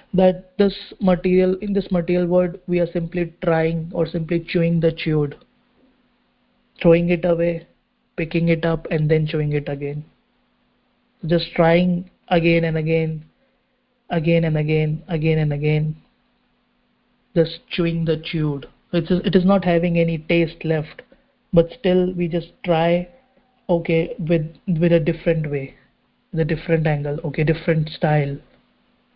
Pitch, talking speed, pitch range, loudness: 170 Hz, 140 wpm, 160-185 Hz, -20 LUFS